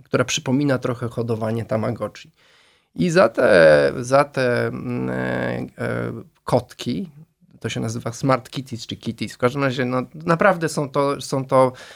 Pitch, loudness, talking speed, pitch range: 125 Hz, -21 LUFS, 145 wpm, 115-140 Hz